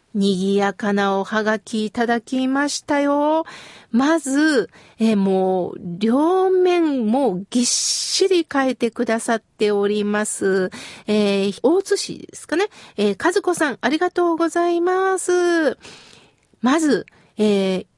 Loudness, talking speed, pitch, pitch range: -19 LUFS, 235 characters per minute, 245 Hz, 205-325 Hz